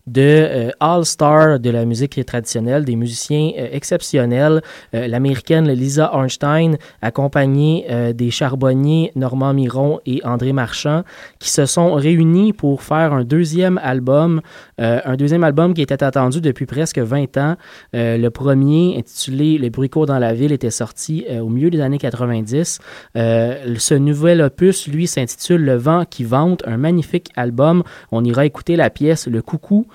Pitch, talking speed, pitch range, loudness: 140 Hz, 165 wpm, 125-160 Hz, -16 LUFS